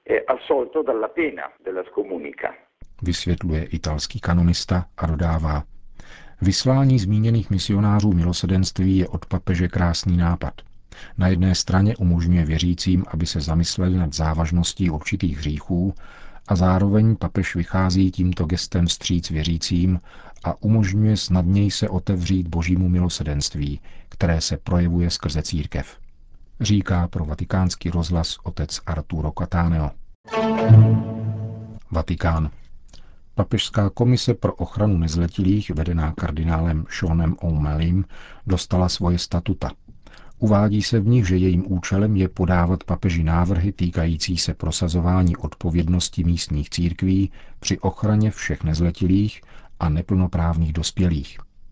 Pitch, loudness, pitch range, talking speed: 90 Hz, -21 LUFS, 85-95 Hz, 105 wpm